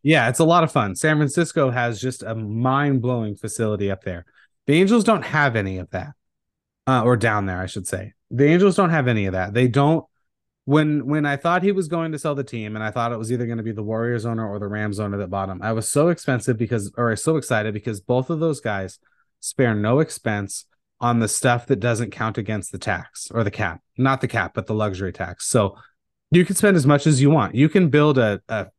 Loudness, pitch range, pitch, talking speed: -21 LUFS, 110-150 Hz, 120 Hz, 250 wpm